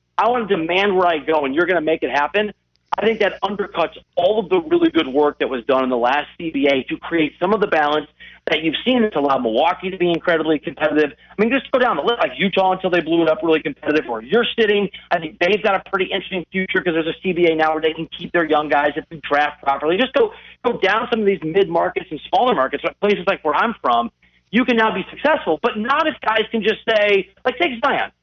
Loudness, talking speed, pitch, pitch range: -18 LUFS, 260 wpm, 180 Hz, 155-215 Hz